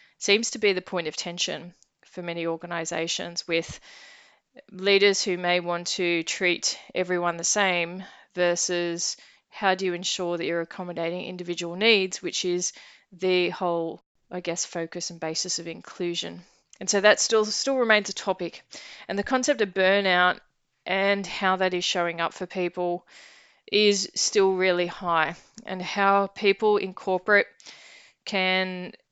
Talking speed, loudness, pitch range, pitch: 150 wpm, -25 LUFS, 175-200 Hz, 180 Hz